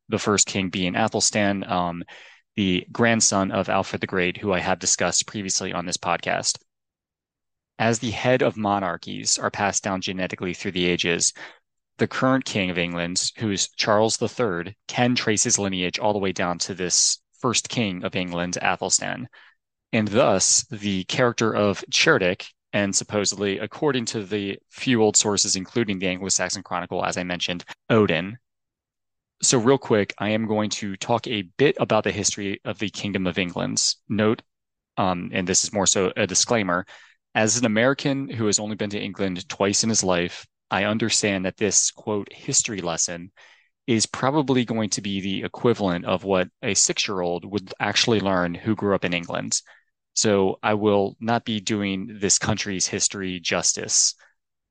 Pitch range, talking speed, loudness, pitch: 95-110 Hz, 170 wpm, -22 LUFS, 100 Hz